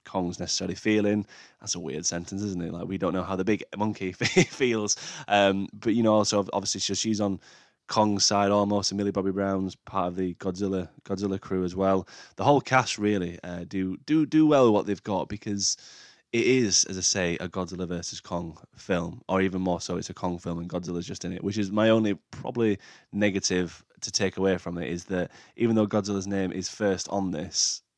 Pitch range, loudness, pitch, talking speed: 90-105 Hz, -27 LUFS, 95 Hz, 210 wpm